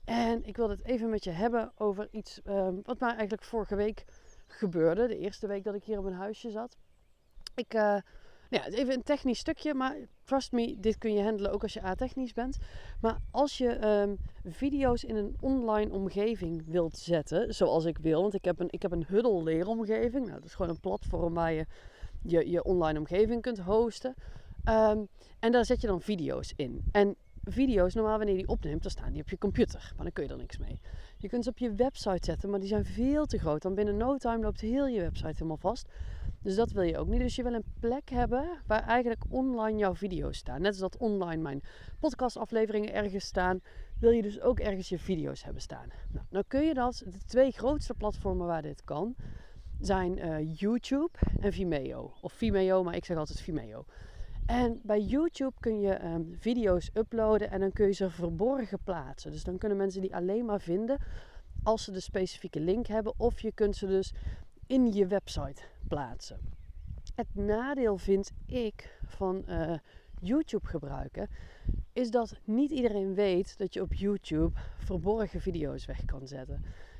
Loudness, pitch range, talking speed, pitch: -32 LUFS, 185-235 Hz, 195 wpm, 210 Hz